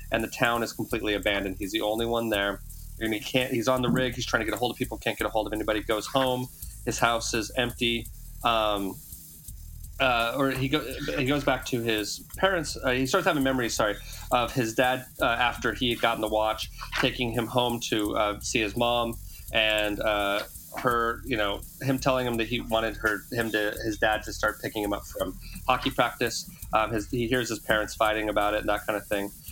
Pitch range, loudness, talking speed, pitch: 105-125 Hz, -27 LUFS, 230 wpm, 115 Hz